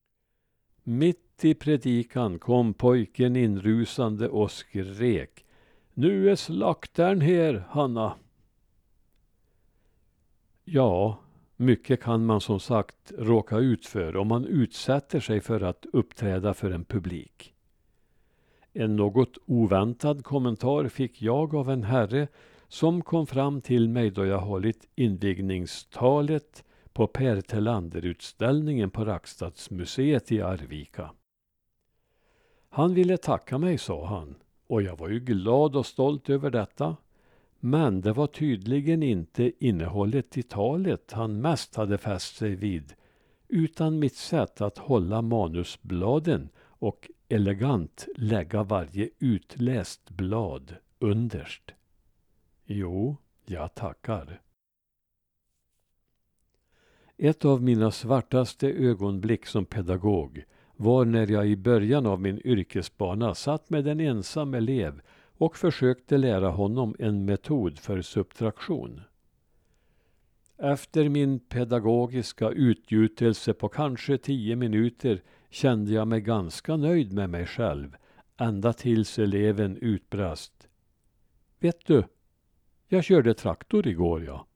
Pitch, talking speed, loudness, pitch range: 115 Hz, 110 wpm, -27 LUFS, 100-135 Hz